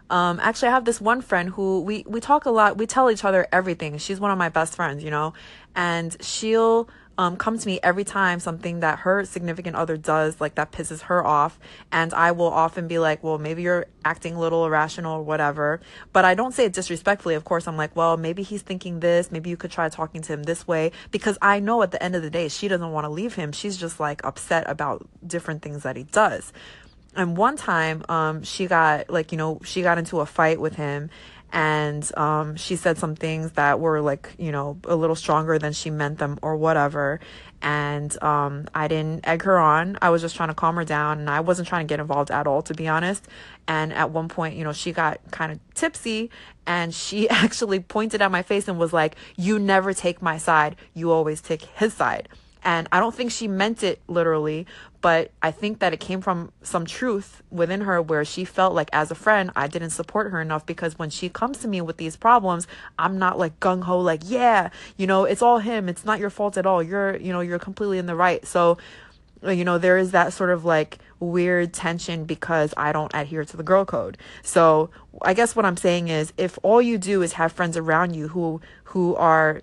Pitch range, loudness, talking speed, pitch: 160-190 Hz, -23 LUFS, 235 wpm, 170 Hz